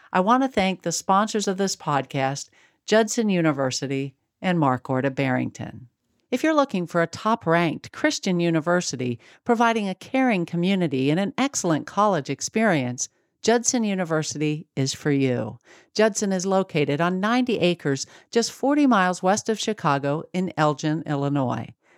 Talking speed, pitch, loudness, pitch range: 145 wpm, 175 Hz, -23 LUFS, 140-215 Hz